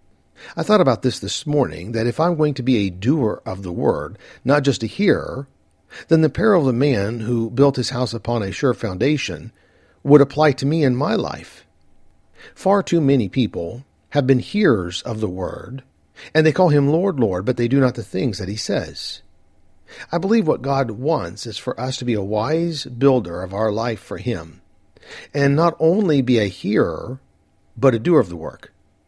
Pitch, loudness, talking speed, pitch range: 125 Hz, -19 LUFS, 200 wpm, 105-145 Hz